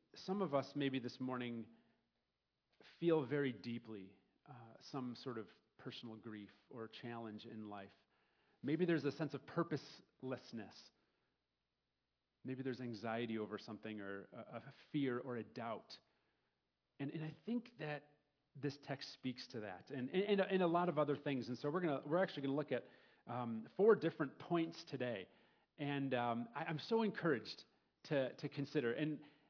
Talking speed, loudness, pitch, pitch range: 170 wpm, -43 LUFS, 135 Hz, 115-150 Hz